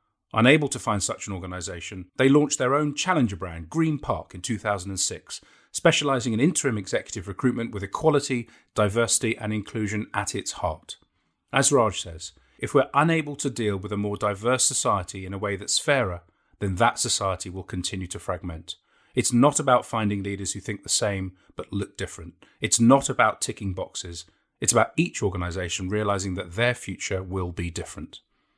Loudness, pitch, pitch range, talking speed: -25 LUFS, 105 Hz, 95-125 Hz, 170 wpm